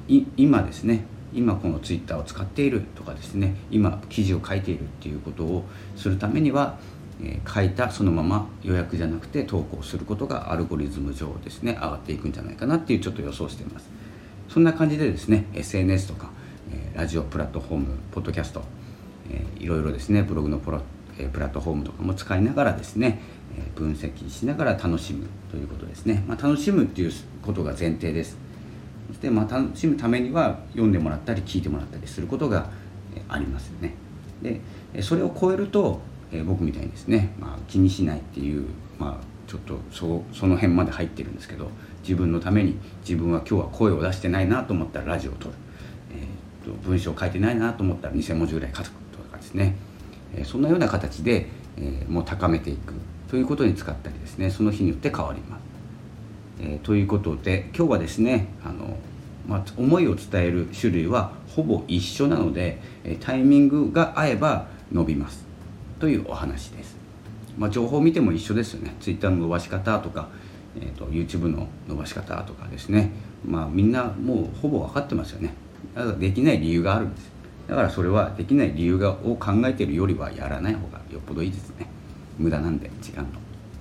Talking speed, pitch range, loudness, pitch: 405 characters per minute, 85-105 Hz, -25 LUFS, 95 Hz